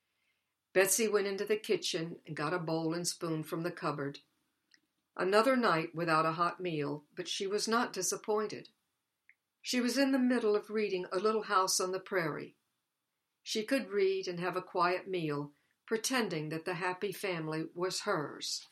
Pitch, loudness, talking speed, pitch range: 185 Hz, -33 LUFS, 170 wpm, 165-210 Hz